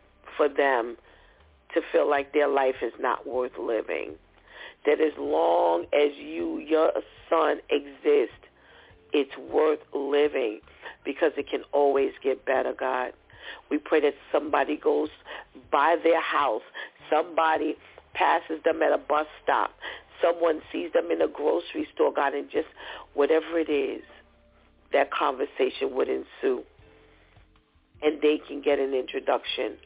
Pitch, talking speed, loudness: 310 Hz, 135 wpm, -26 LUFS